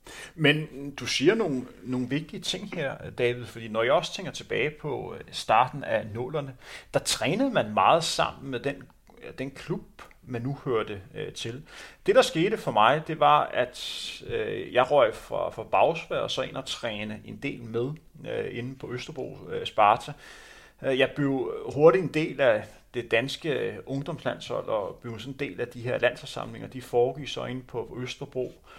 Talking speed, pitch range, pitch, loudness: 185 wpm, 120-160 Hz, 135 Hz, -27 LUFS